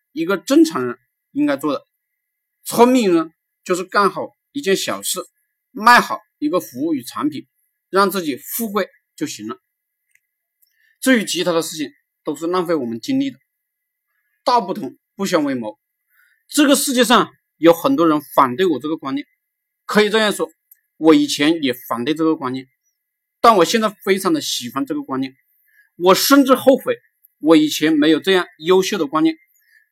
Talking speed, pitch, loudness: 245 characters per minute, 255 Hz, -17 LUFS